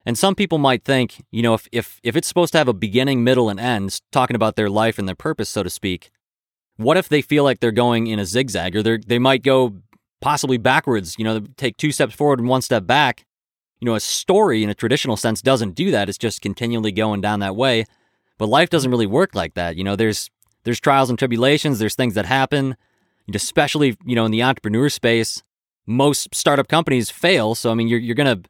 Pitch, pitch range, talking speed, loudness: 120 Hz, 110-135 Hz, 230 wpm, -19 LUFS